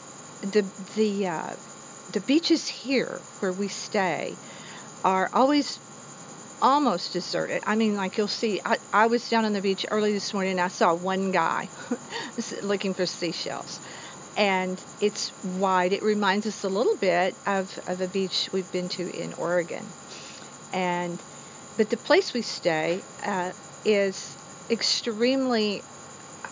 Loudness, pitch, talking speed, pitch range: -26 LUFS, 195 Hz, 145 wpm, 185-220 Hz